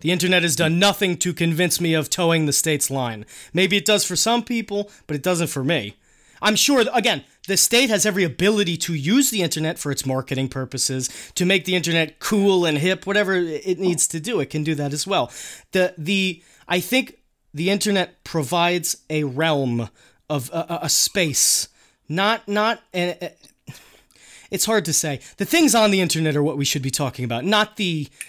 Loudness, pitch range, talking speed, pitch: -20 LUFS, 150-200 Hz, 195 wpm, 175 Hz